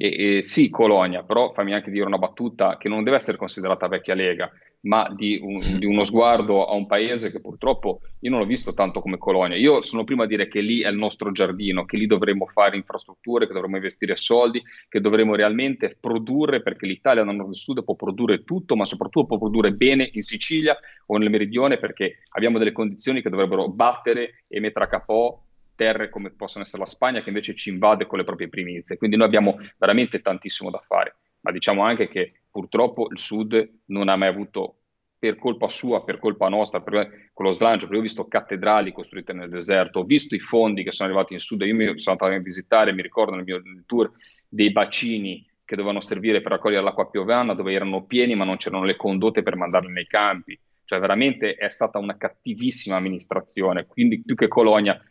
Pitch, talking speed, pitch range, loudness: 105 Hz, 210 wpm, 95-115 Hz, -22 LUFS